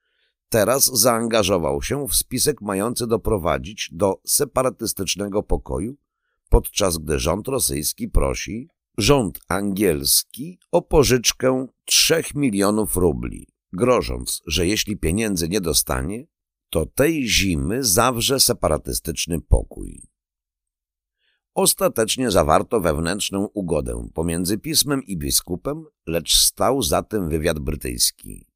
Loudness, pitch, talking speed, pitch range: -20 LUFS, 100 Hz, 100 wpm, 80-120 Hz